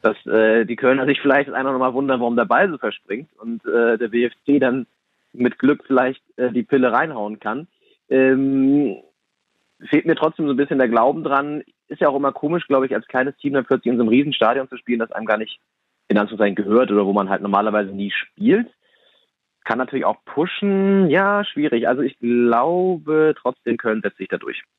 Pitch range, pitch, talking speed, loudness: 115-140 Hz, 130 Hz, 210 wpm, -19 LUFS